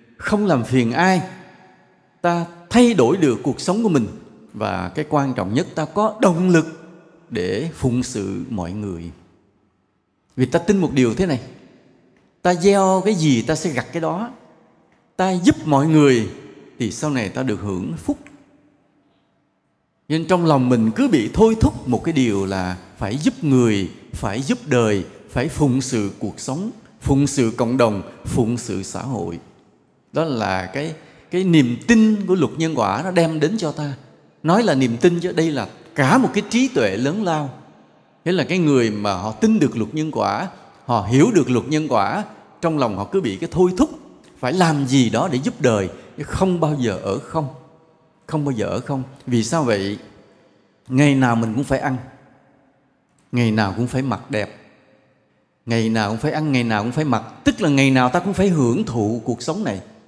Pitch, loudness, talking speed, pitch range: 140 Hz, -19 LUFS, 190 wpm, 115-170 Hz